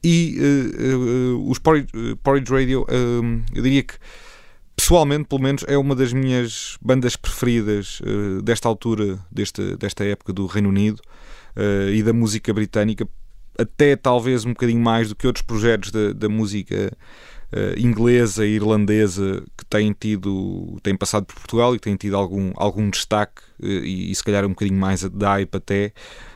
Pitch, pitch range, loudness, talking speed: 110 Hz, 100-125 Hz, -20 LUFS, 175 wpm